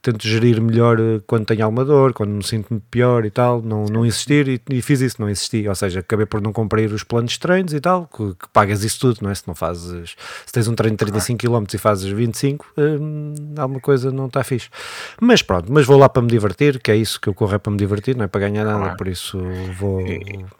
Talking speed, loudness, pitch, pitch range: 245 wpm, -18 LUFS, 110 Hz, 105-130 Hz